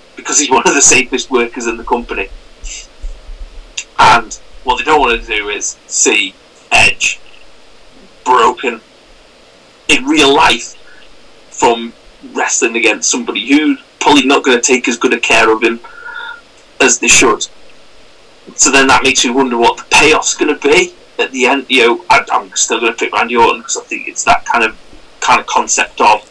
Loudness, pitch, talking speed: -10 LUFS, 340 Hz, 180 wpm